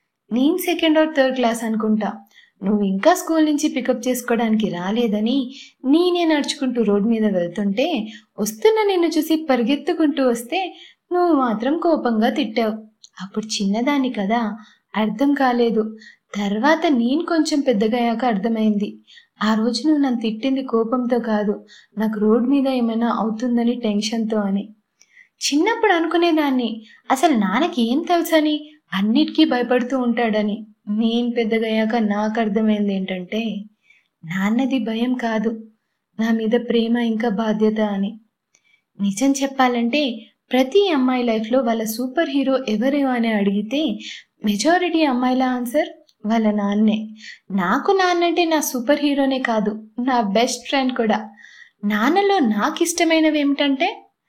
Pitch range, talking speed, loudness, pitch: 215-290 Hz, 115 wpm, -19 LUFS, 240 Hz